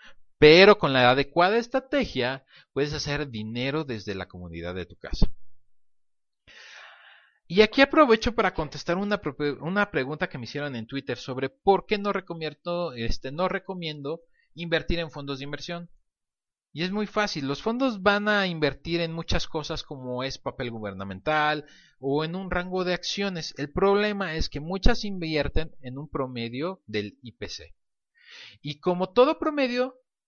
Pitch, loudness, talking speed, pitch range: 155 Hz, -26 LUFS, 155 wpm, 135-190 Hz